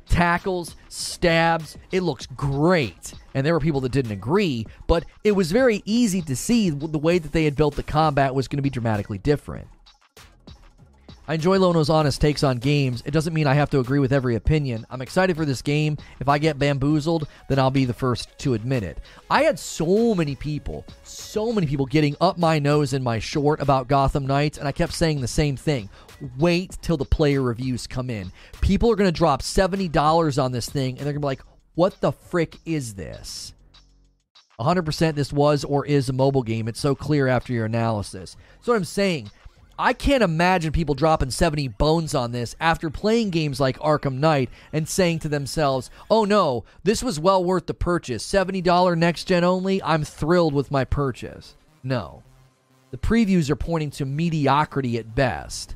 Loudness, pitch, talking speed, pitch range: -22 LUFS, 150 Hz, 195 wpm, 130-170 Hz